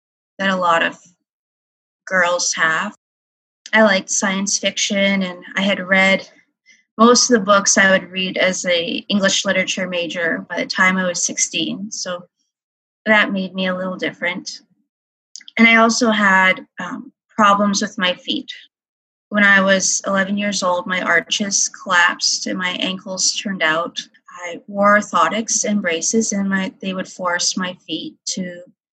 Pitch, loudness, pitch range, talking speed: 195 Hz, -16 LUFS, 180-220 Hz, 155 wpm